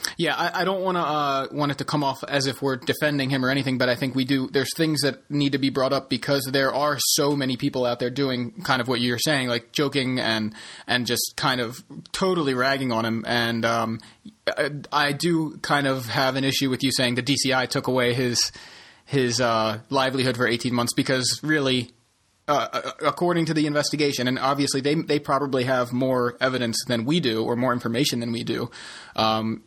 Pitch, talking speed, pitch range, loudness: 135 Hz, 215 wpm, 120-145 Hz, -23 LUFS